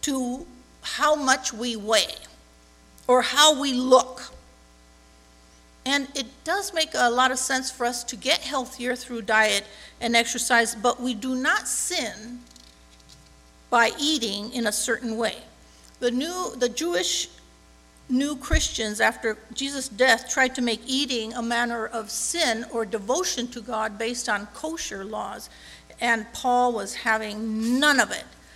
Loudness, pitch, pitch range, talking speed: -24 LUFS, 235 Hz, 215-260 Hz, 145 wpm